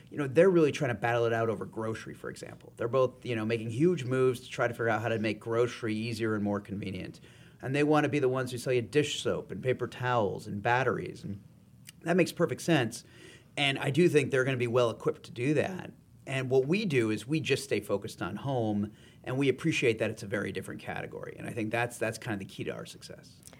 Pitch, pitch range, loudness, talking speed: 125 Hz, 115-145 Hz, -30 LUFS, 255 wpm